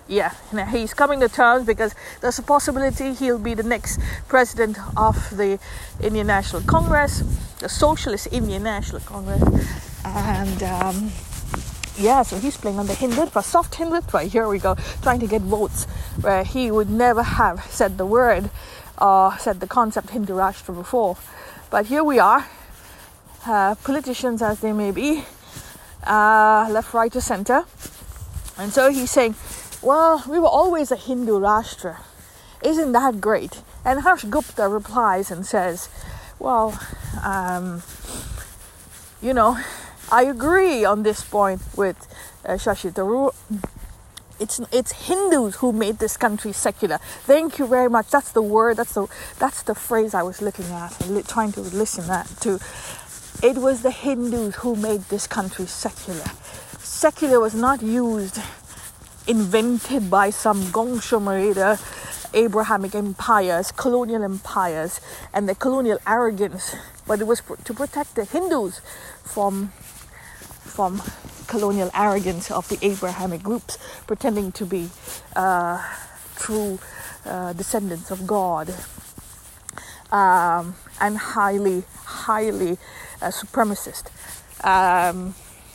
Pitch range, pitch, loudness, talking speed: 195-245 Hz, 215 Hz, -21 LUFS, 135 wpm